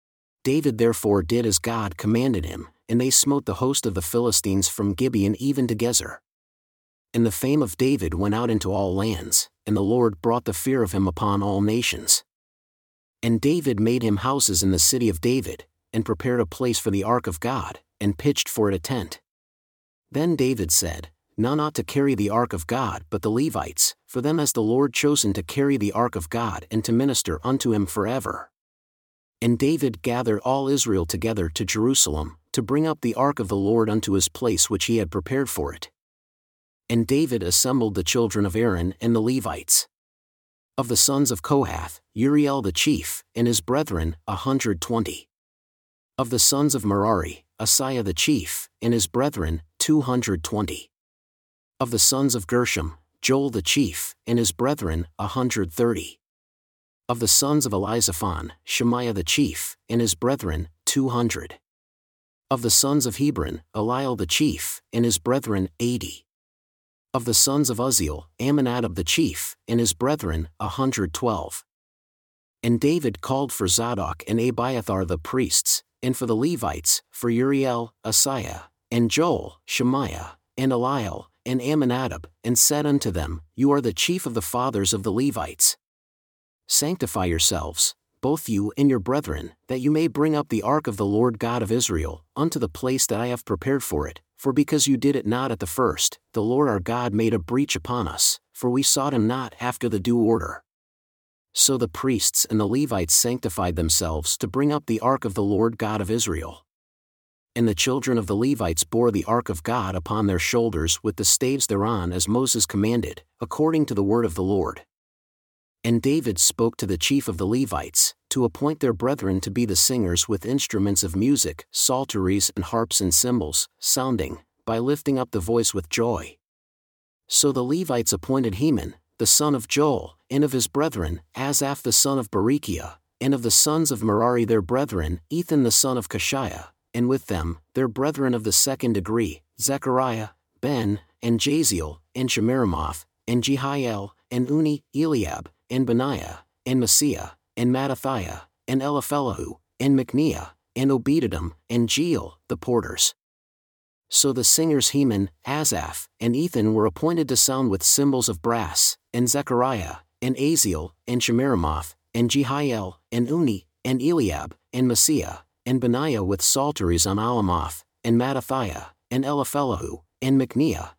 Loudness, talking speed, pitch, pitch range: -22 LUFS, 175 wpm, 115 Hz, 95-130 Hz